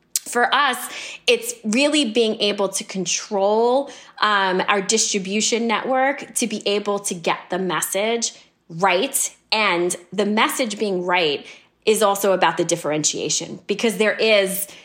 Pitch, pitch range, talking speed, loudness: 205 Hz, 190-230 Hz, 135 wpm, -20 LUFS